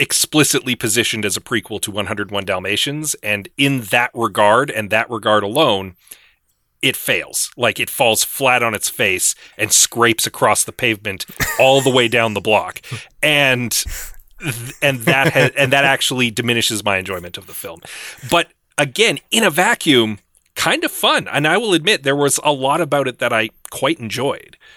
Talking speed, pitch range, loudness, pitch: 175 wpm, 105-140 Hz, -16 LUFS, 120 Hz